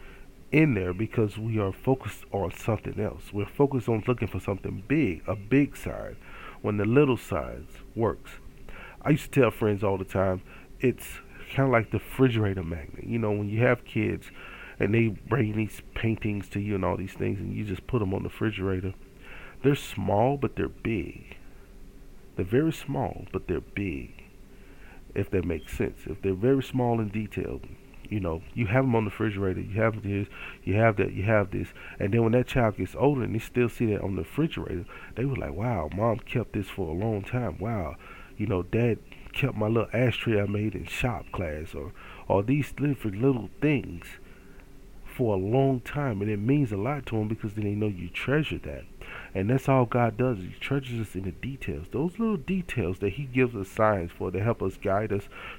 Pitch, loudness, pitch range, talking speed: 105 Hz, -28 LUFS, 95-125 Hz, 205 wpm